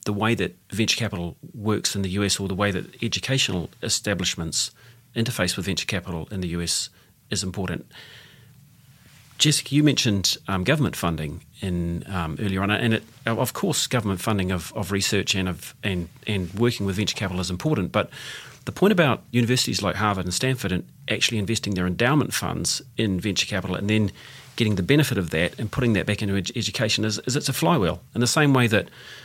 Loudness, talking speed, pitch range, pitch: -24 LUFS, 195 wpm, 95-125 Hz, 105 Hz